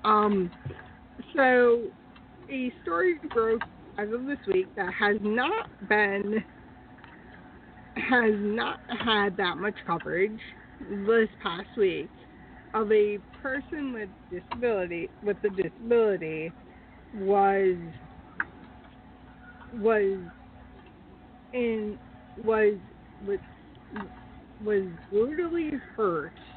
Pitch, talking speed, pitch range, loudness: 215 Hz, 85 wpm, 200-250 Hz, -28 LUFS